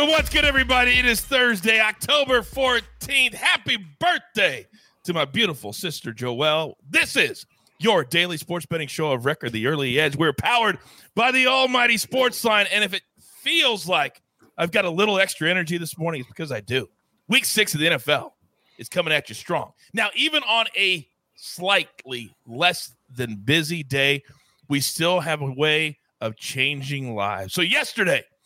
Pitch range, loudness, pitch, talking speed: 140-225 Hz, -21 LUFS, 170 Hz, 170 wpm